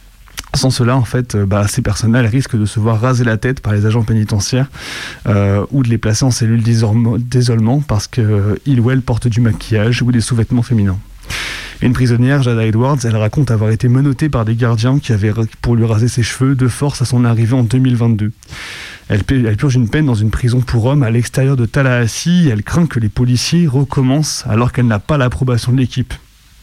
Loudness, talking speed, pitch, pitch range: -14 LUFS, 210 wpm, 120 Hz, 110-130 Hz